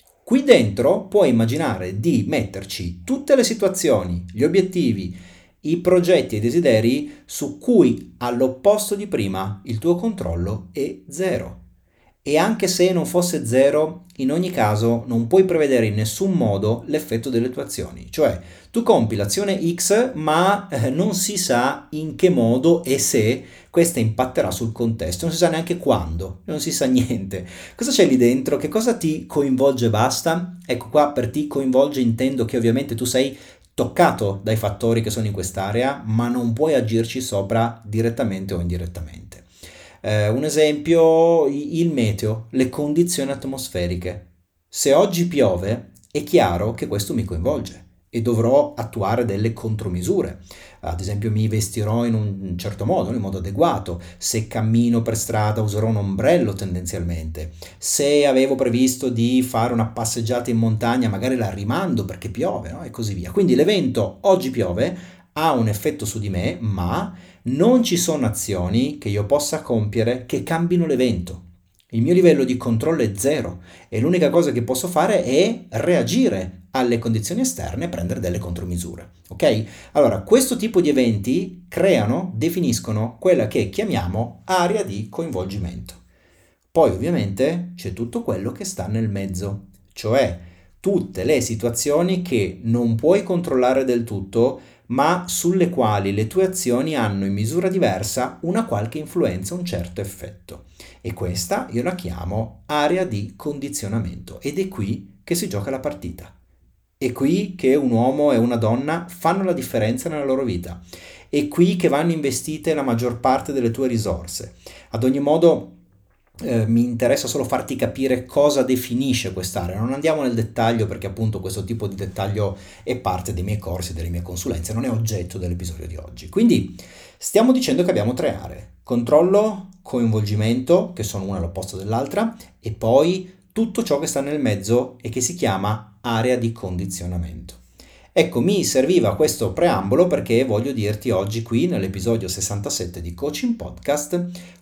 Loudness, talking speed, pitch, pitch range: -20 LUFS, 155 wpm, 115 Hz, 95-150 Hz